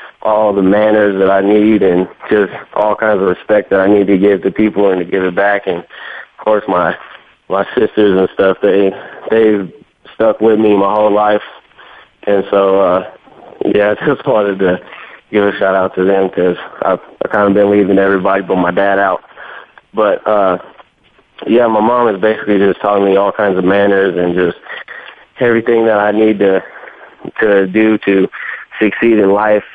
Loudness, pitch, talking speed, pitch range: -12 LUFS, 100 Hz, 190 wpm, 95-105 Hz